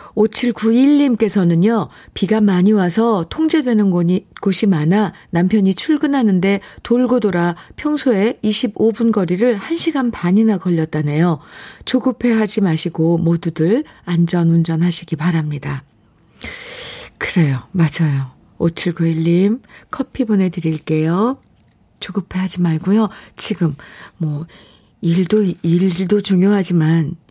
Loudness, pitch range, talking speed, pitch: -16 LUFS, 170-225 Hz, 230 characters per minute, 190 Hz